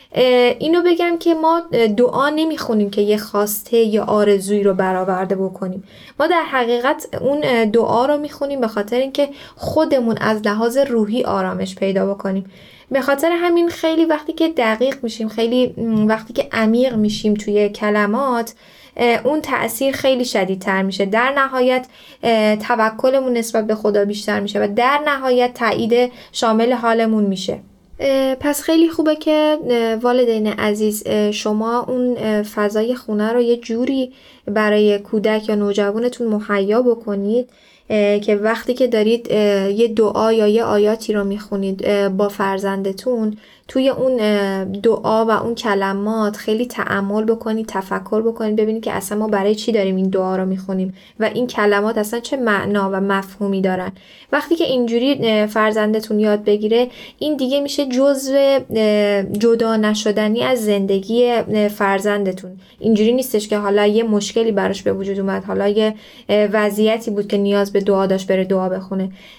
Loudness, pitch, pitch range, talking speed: -17 LUFS, 220 Hz, 205-245 Hz, 145 wpm